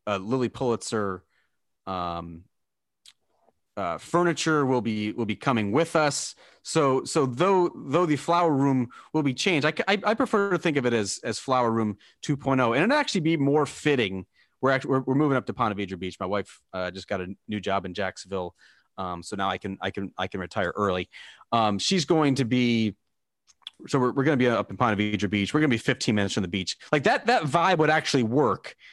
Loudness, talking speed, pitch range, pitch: -25 LUFS, 220 wpm, 100-150 Hz, 120 Hz